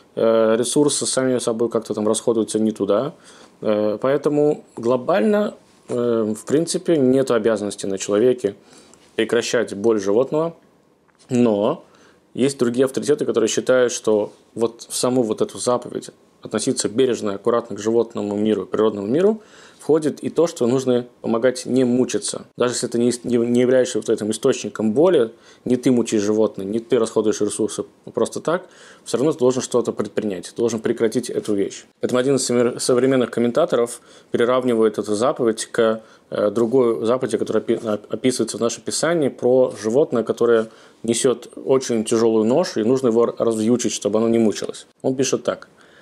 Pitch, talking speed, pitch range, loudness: 115 Hz, 145 wpm, 110-125 Hz, -20 LUFS